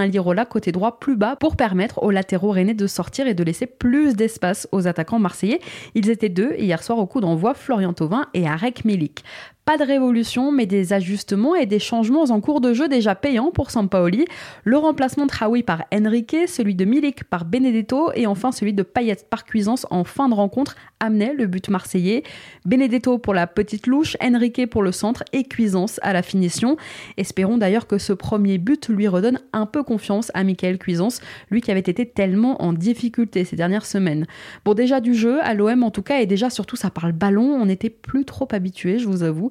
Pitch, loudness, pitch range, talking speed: 215 Hz, -20 LUFS, 195-250 Hz, 210 wpm